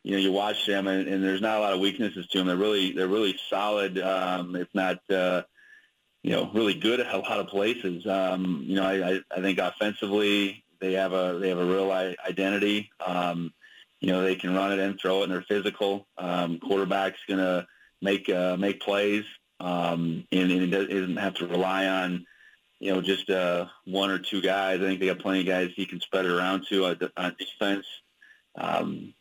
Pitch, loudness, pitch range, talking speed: 95 Hz, -27 LUFS, 90-100 Hz, 210 wpm